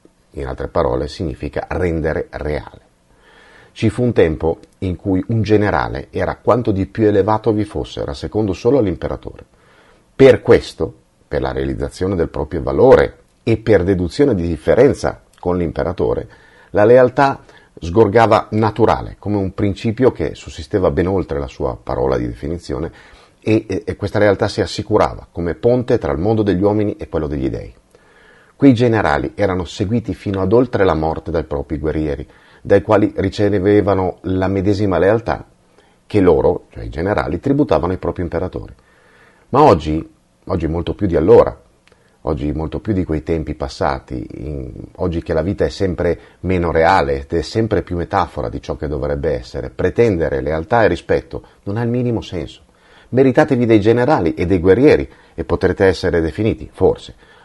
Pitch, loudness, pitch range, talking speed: 95 Hz, -17 LUFS, 80-110 Hz, 160 wpm